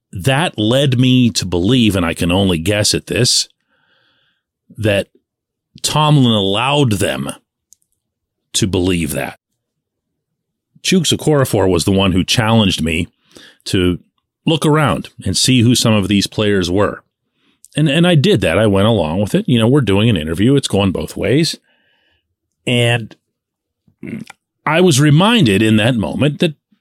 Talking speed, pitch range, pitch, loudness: 150 wpm, 95-140 Hz, 110 Hz, -14 LUFS